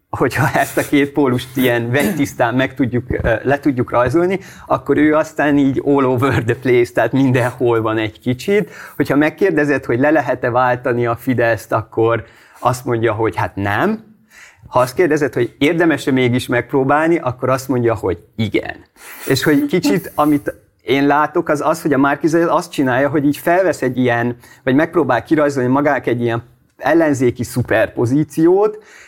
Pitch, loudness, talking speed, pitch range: 130 Hz, -16 LUFS, 160 wpm, 120-150 Hz